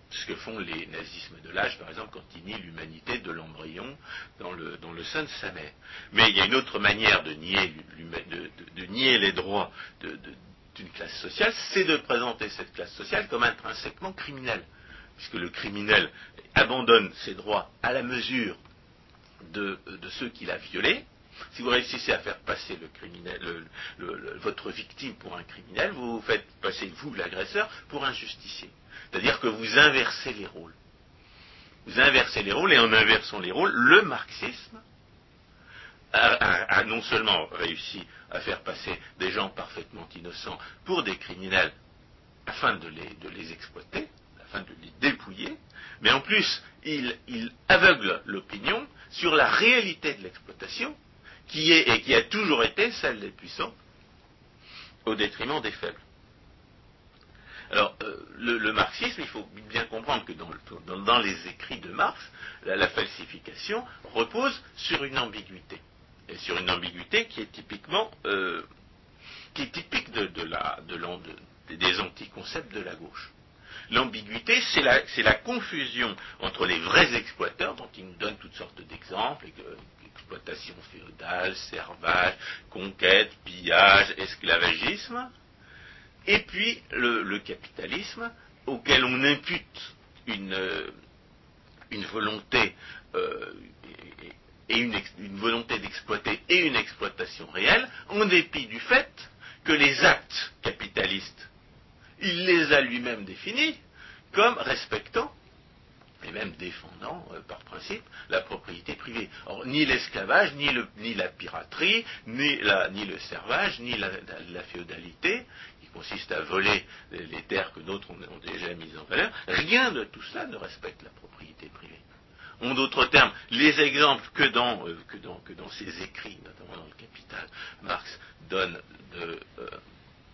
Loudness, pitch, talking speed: -25 LUFS, 125 Hz, 155 wpm